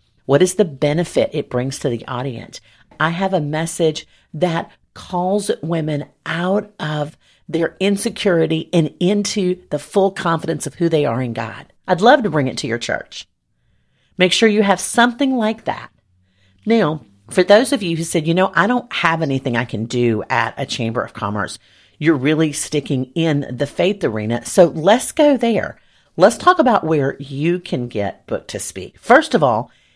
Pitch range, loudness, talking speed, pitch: 130-185 Hz, -18 LUFS, 180 wpm, 160 Hz